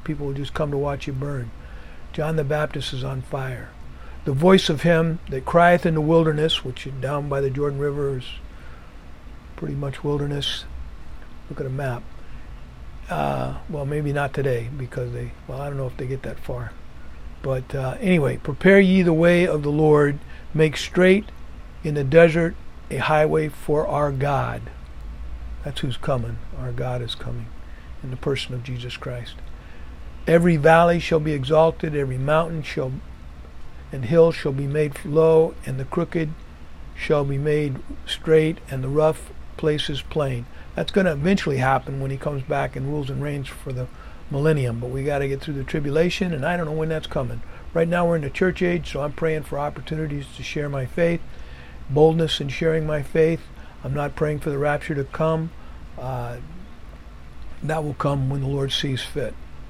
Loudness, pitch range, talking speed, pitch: -22 LUFS, 125-155 Hz, 185 wpm, 140 Hz